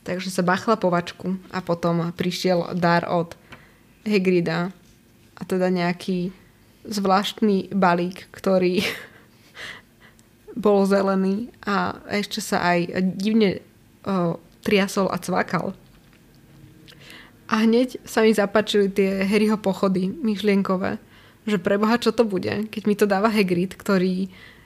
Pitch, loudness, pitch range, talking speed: 195 Hz, -22 LUFS, 180-210 Hz, 115 wpm